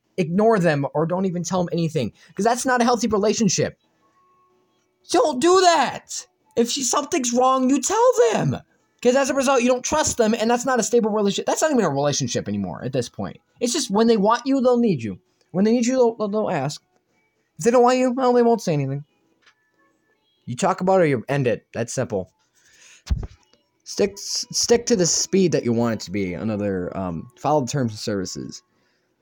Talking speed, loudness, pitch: 205 wpm, -21 LUFS, 210 Hz